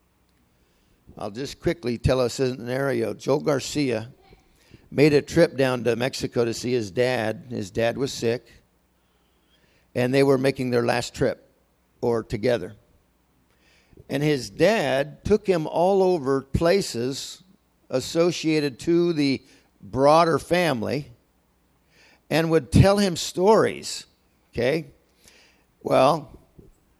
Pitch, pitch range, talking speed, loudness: 130 Hz, 115-150 Hz, 115 wpm, -23 LUFS